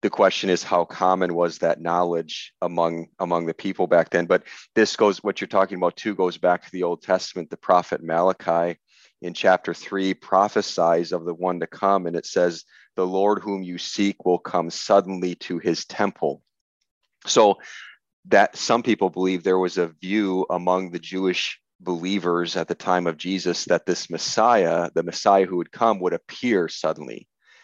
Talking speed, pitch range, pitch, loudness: 180 wpm, 85-95 Hz, 90 Hz, -22 LUFS